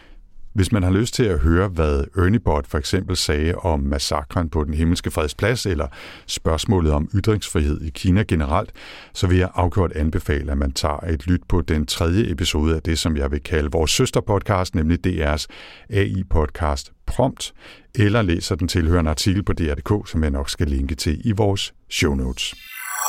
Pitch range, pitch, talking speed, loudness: 75-95 Hz, 85 Hz, 180 wpm, -21 LUFS